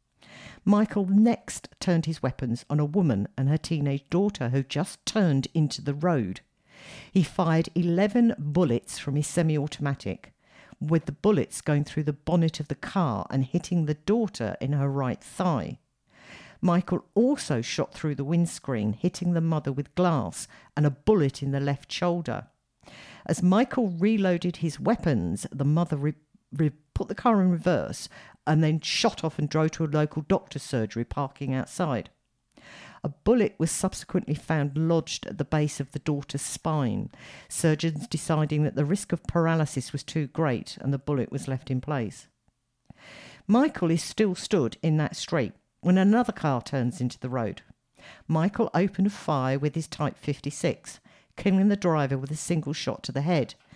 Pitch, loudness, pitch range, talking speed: 155 Hz, -27 LUFS, 140-180 Hz, 165 wpm